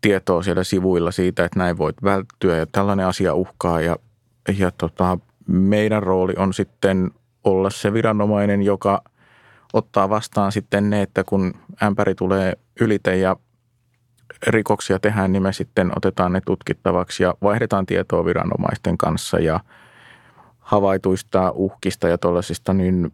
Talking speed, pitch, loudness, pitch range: 135 wpm, 95 Hz, -20 LUFS, 95-105 Hz